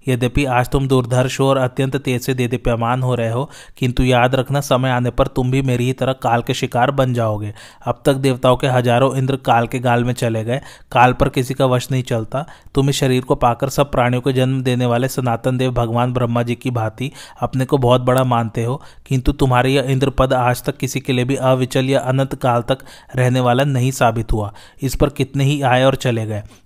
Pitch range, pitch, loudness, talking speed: 120-135 Hz, 130 Hz, -17 LUFS, 225 wpm